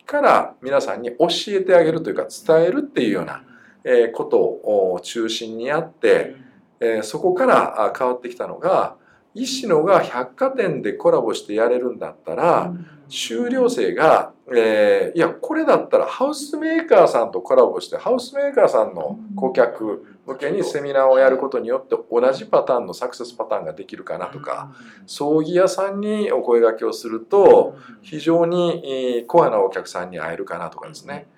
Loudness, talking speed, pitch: -19 LUFS, 350 characters per minute, 265 Hz